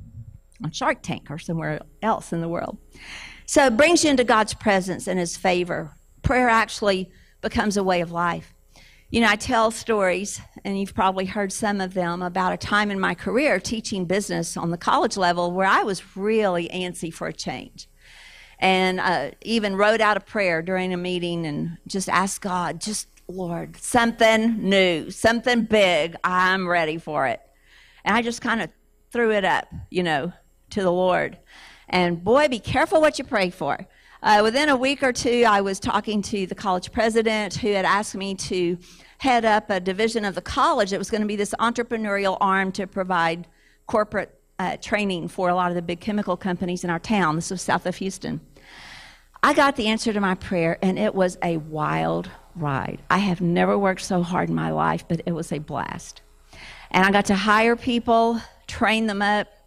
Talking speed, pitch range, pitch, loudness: 195 wpm, 180-220 Hz, 195 Hz, -22 LUFS